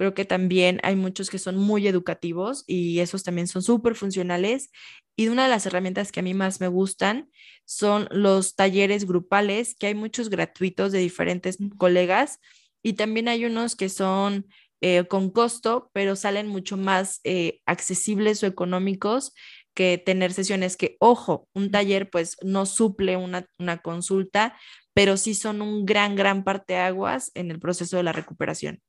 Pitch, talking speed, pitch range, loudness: 195 Hz, 170 wpm, 185-210 Hz, -24 LUFS